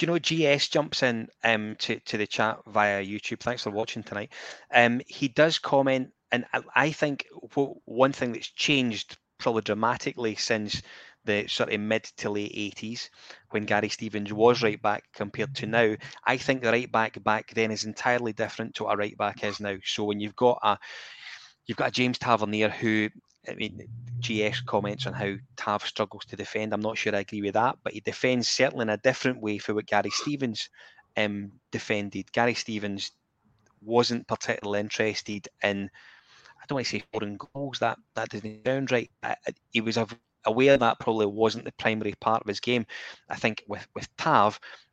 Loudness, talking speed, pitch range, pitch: -27 LUFS, 190 wpm, 105-125 Hz, 110 Hz